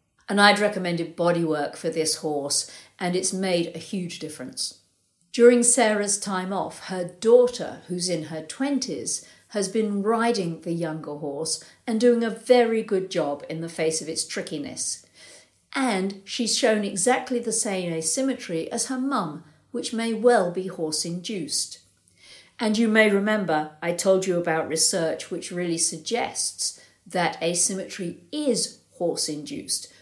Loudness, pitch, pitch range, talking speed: -24 LUFS, 185 Hz, 160-225 Hz, 150 wpm